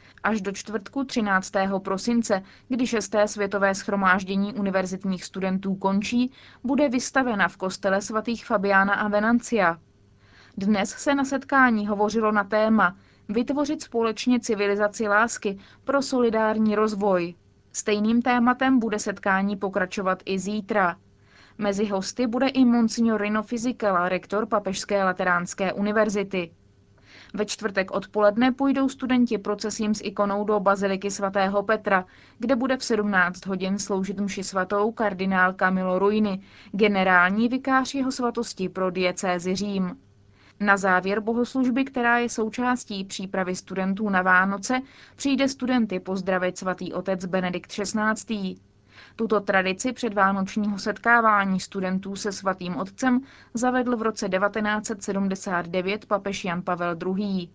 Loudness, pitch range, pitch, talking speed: -24 LUFS, 190-225 Hz, 205 Hz, 120 wpm